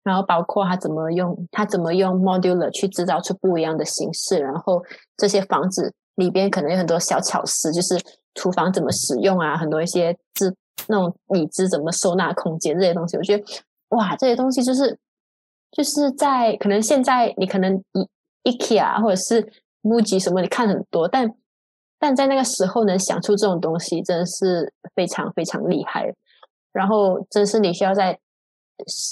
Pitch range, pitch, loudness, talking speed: 175-210 Hz, 190 Hz, -20 LUFS, 290 characters per minute